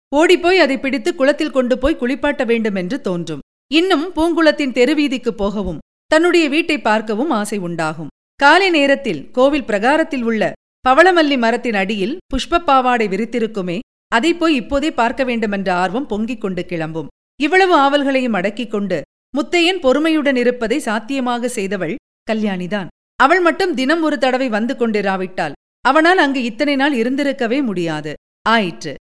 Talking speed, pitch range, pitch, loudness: 125 wpm, 210-295 Hz, 255 Hz, -16 LUFS